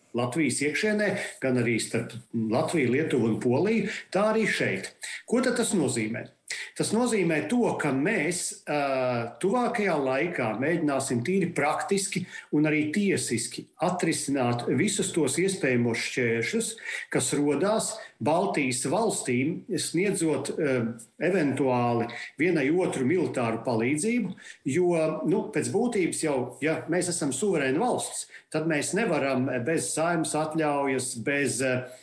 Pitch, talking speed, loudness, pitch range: 150 Hz, 120 wpm, -27 LUFS, 125-185 Hz